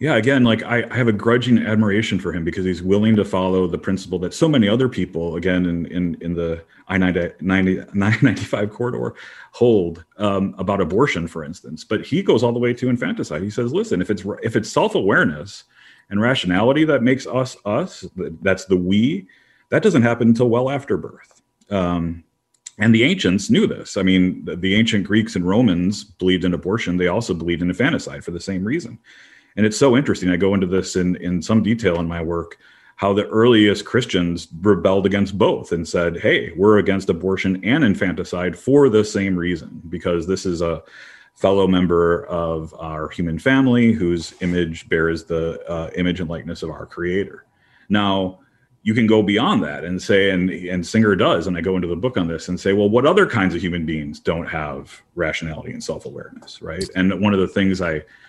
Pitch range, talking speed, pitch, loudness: 85-110 Hz, 200 wpm, 95 Hz, -19 LUFS